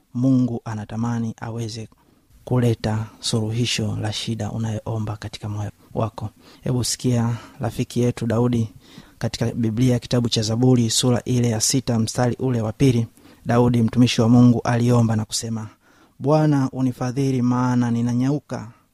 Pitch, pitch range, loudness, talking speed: 120 Hz, 110-125 Hz, -21 LUFS, 125 wpm